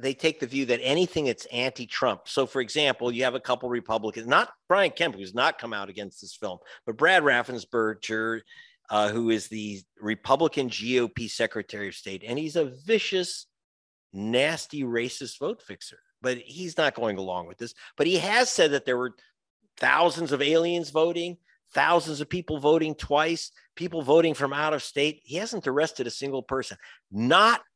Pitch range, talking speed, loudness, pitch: 115-160 Hz, 175 wpm, -26 LUFS, 135 Hz